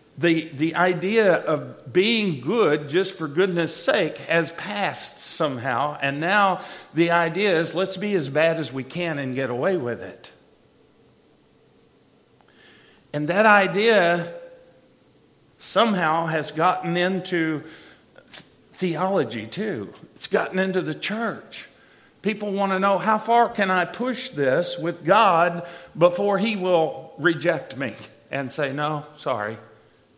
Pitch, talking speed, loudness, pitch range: 175 Hz, 130 wpm, -22 LUFS, 155-190 Hz